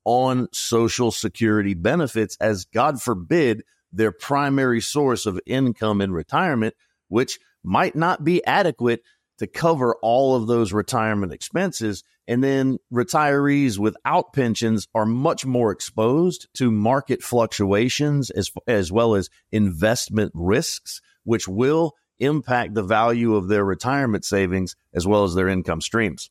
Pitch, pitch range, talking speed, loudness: 115 Hz, 105-135 Hz, 135 wpm, -21 LUFS